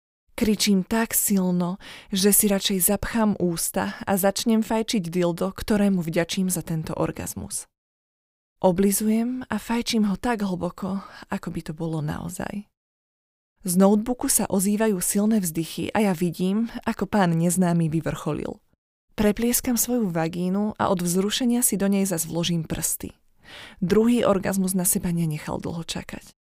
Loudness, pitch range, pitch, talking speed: -23 LUFS, 175-215 Hz, 195 Hz, 135 wpm